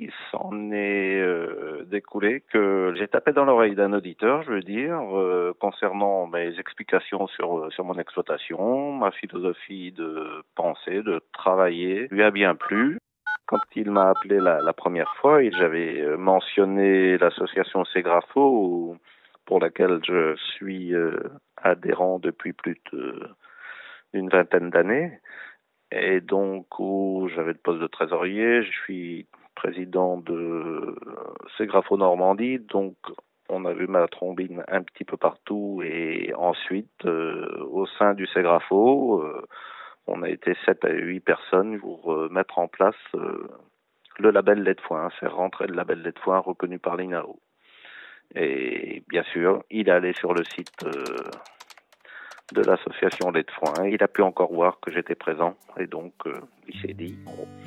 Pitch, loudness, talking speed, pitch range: 95 Hz, -24 LUFS, 155 wpm, 90-100 Hz